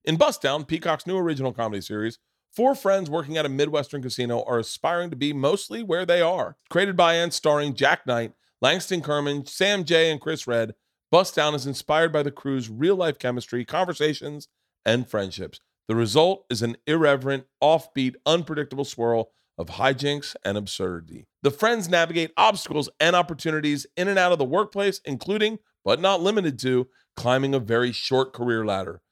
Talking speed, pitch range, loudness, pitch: 175 wpm, 125-170 Hz, -24 LUFS, 145 Hz